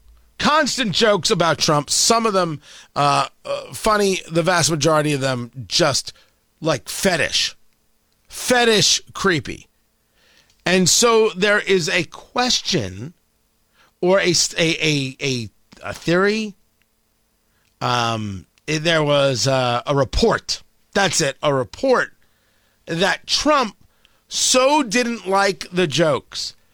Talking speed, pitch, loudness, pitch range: 115 wpm, 165 Hz, -18 LUFS, 125-205 Hz